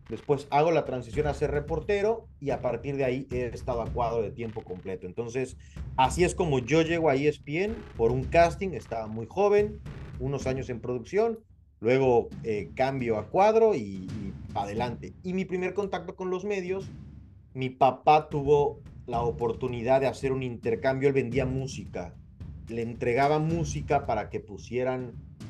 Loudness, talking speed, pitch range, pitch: -28 LUFS, 165 wpm, 115-160 Hz, 130 Hz